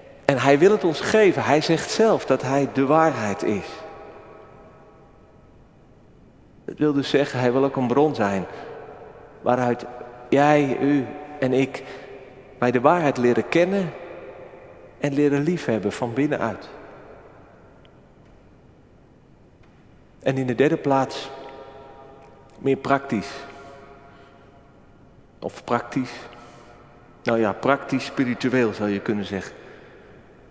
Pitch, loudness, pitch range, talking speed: 135 Hz, -22 LUFS, 120-140 Hz, 110 wpm